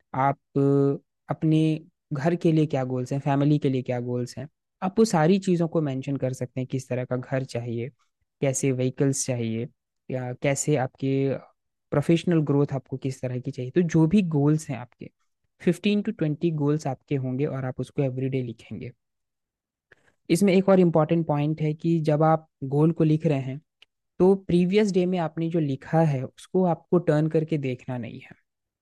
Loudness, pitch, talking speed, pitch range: -25 LUFS, 145 Hz, 180 wpm, 130-165 Hz